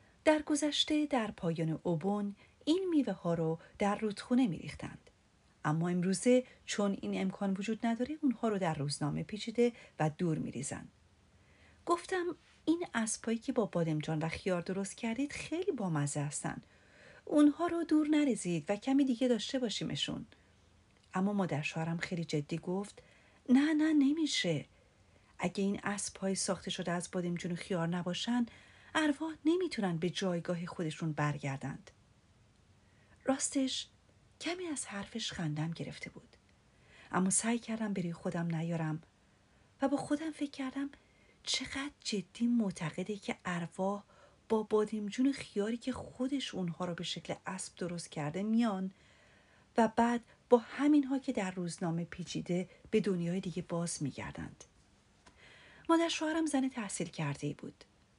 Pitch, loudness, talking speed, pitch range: 195 Hz, -35 LUFS, 135 wpm, 170-255 Hz